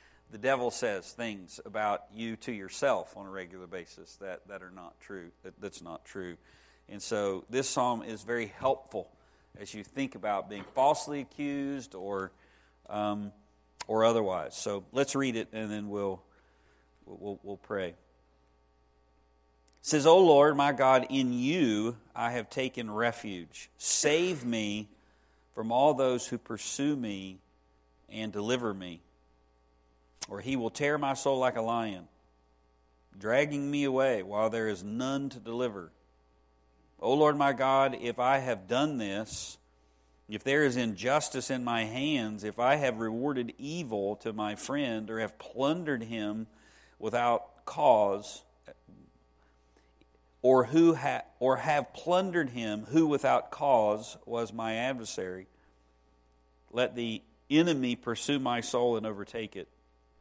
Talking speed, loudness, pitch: 145 wpm, -30 LUFS, 110 Hz